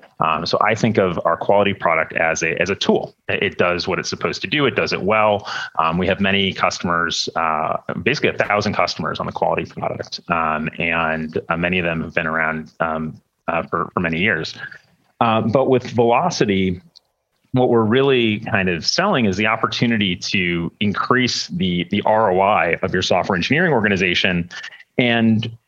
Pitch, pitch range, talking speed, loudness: 100 Hz, 85-115 Hz, 180 wpm, -18 LUFS